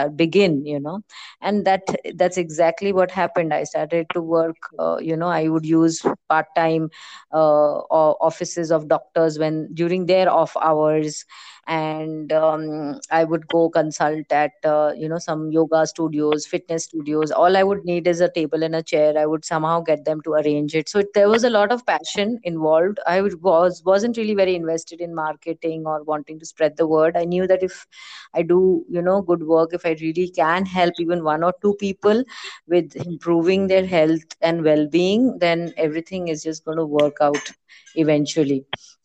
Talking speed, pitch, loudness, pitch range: 185 wpm, 165 Hz, -20 LUFS, 155-180 Hz